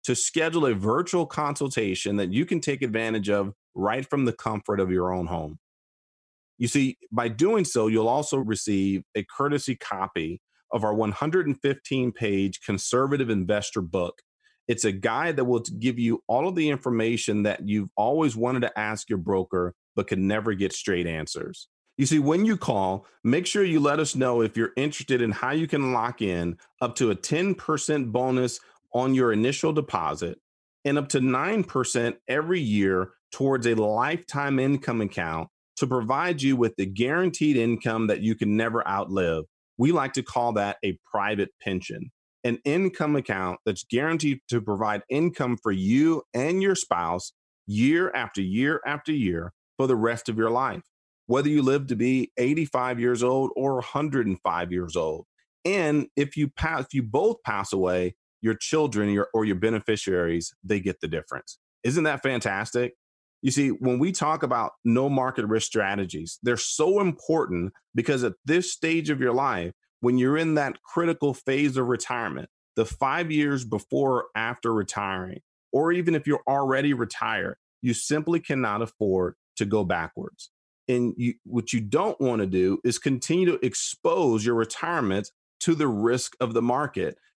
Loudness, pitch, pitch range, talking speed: -26 LUFS, 120 Hz, 105-145 Hz, 170 wpm